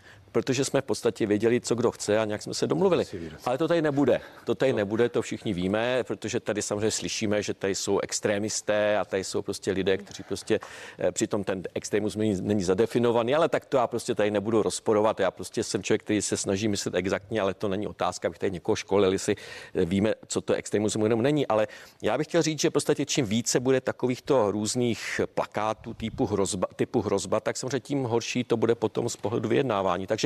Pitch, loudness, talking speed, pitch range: 110 Hz, -27 LUFS, 205 wpm, 105-125 Hz